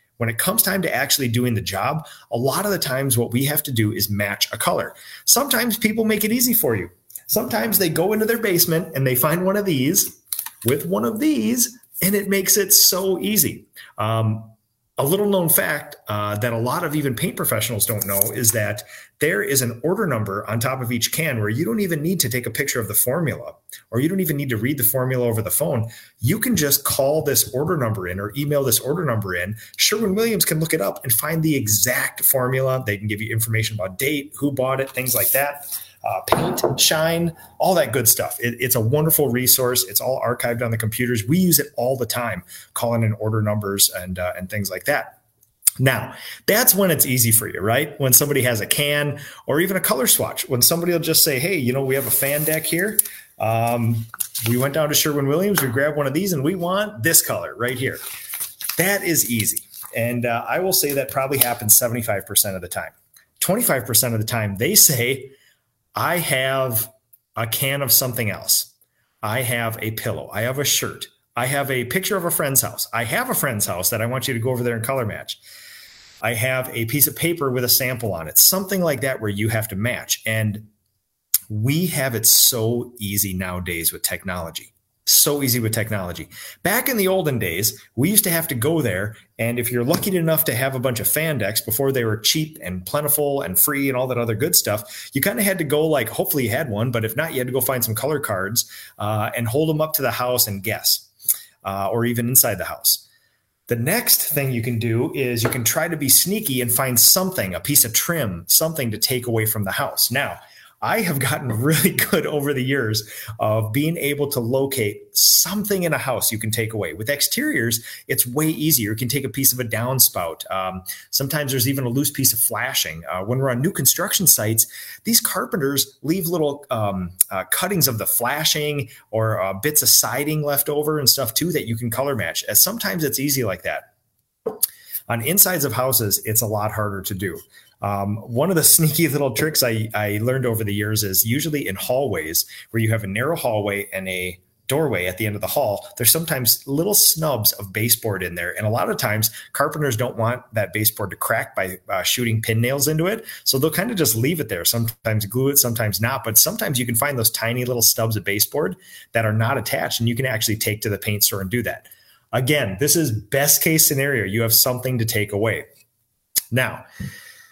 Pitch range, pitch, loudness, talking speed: 110-150 Hz, 125 Hz, -19 LUFS, 225 wpm